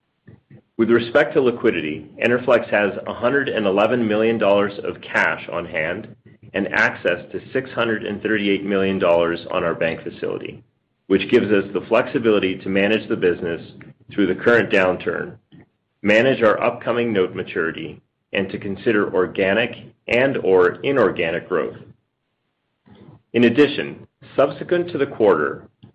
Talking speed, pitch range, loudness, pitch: 125 wpm, 100-130 Hz, -19 LUFS, 110 Hz